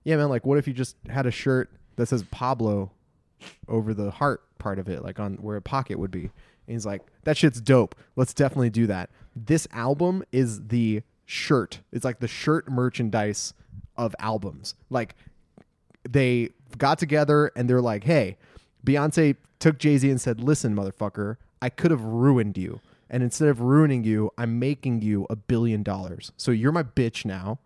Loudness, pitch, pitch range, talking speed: -25 LUFS, 120 Hz, 105-135 Hz, 185 wpm